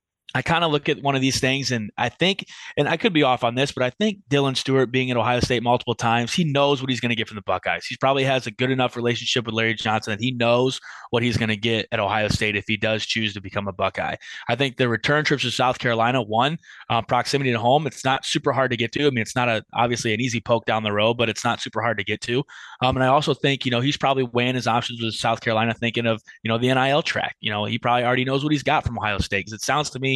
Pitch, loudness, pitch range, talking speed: 120 Hz, -22 LUFS, 115-135 Hz, 295 wpm